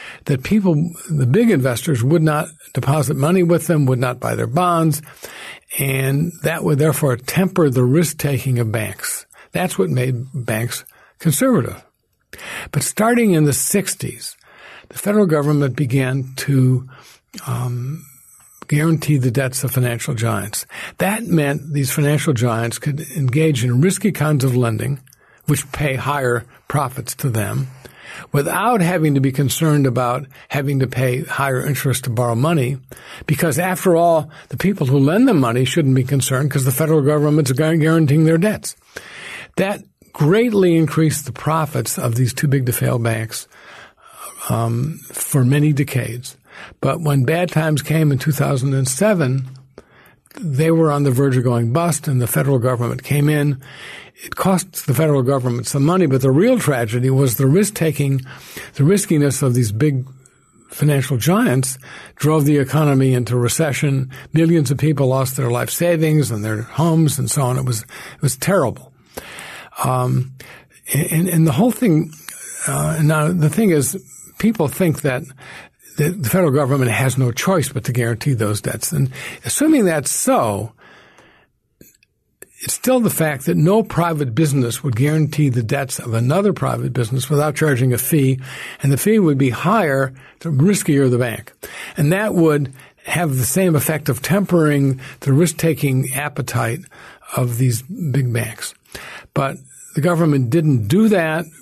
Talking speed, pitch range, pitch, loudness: 155 wpm, 130-160 Hz, 145 Hz, -17 LUFS